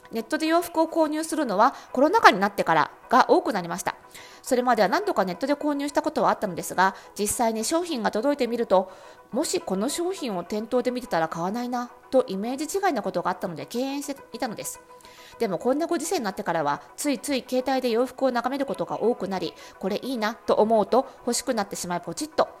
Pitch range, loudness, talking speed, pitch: 205-295 Hz, -25 LUFS, 450 characters per minute, 250 Hz